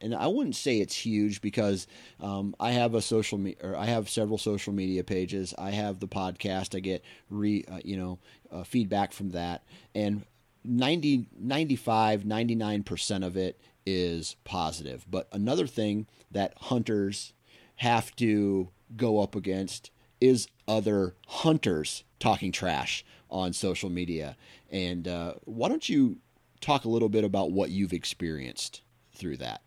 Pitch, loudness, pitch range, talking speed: 100 Hz, -30 LUFS, 95-115 Hz, 150 wpm